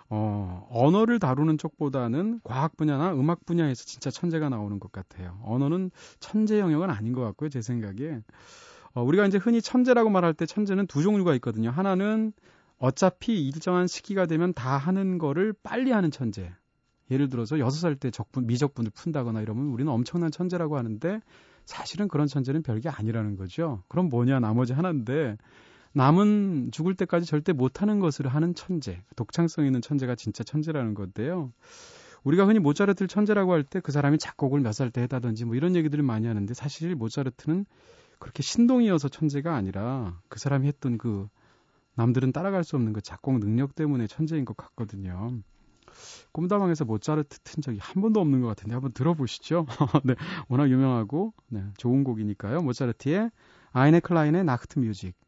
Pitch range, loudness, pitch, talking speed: 120-175 Hz, -26 LUFS, 145 Hz, 385 characters per minute